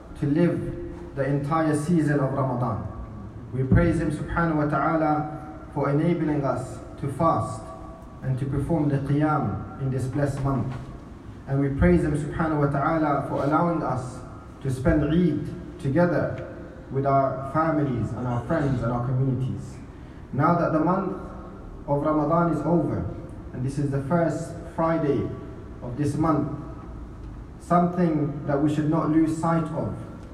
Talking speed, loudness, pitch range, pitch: 150 wpm, -25 LUFS, 130-160 Hz, 145 Hz